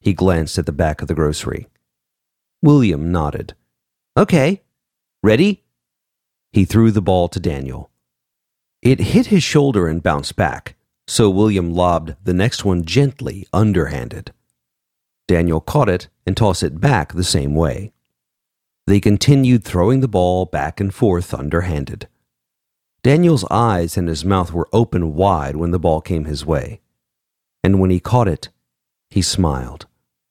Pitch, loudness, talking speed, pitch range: 90 Hz, -17 LUFS, 145 wpm, 75-100 Hz